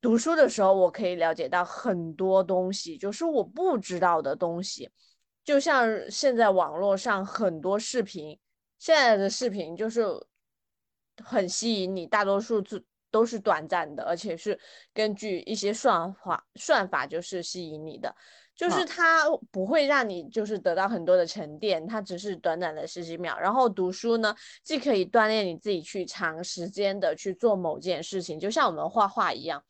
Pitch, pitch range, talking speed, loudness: 195 Hz, 180-225 Hz, 260 characters per minute, -27 LUFS